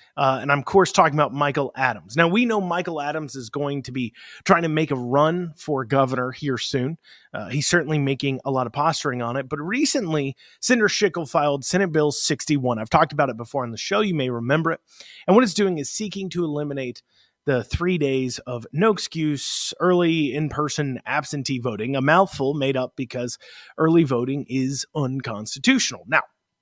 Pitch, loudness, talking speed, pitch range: 145 Hz, -22 LUFS, 195 wpm, 130-165 Hz